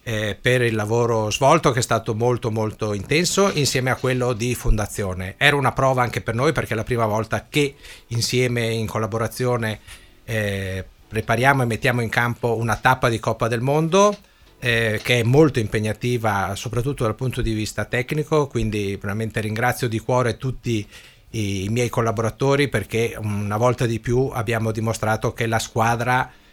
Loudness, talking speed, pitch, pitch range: -21 LUFS, 165 wpm, 115 Hz, 110-125 Hz